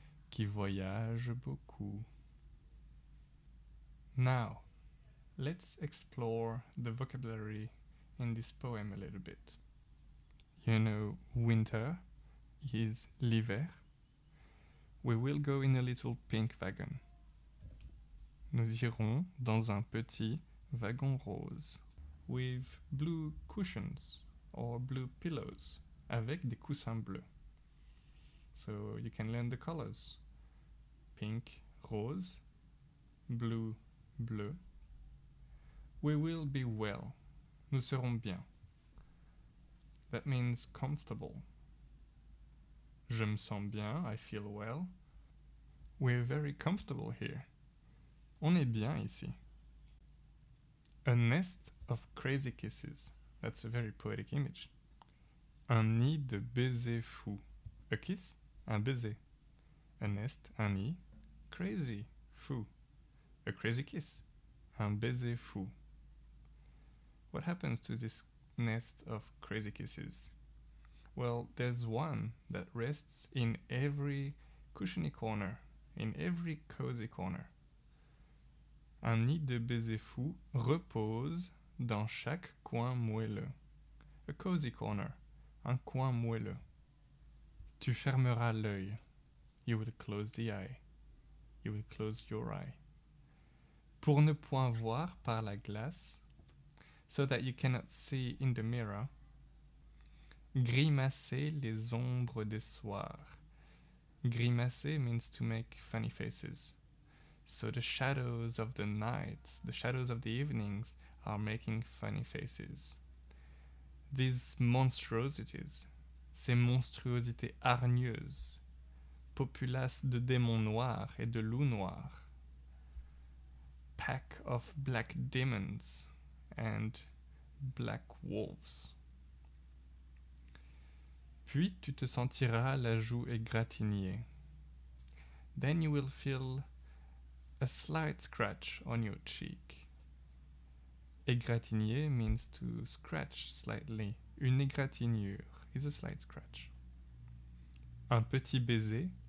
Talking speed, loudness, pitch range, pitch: 100 wpm, -39 LUFS, 100-135 Hz, 115 Hz